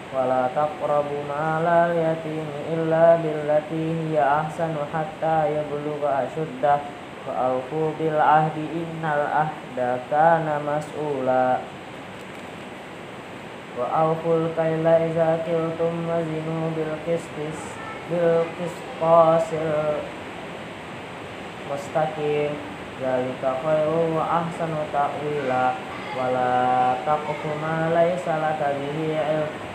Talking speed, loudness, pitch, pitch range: 75 wpm, -23 LUFS, 155 Hz, 145-165 Hz